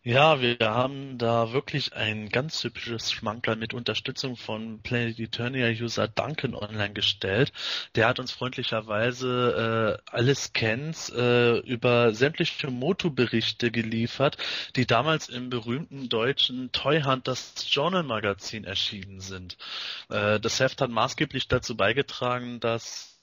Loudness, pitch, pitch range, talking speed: -26 LUFS, 120 Hz, 110-130 Hz, 125 wpm